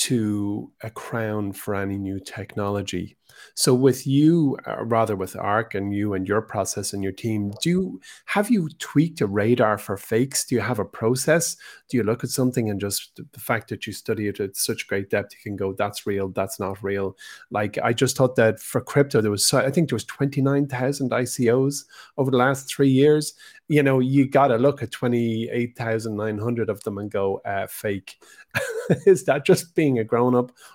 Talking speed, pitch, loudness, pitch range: 215 wpm, 115 Hz, -23 LUFS, 105-135 Hz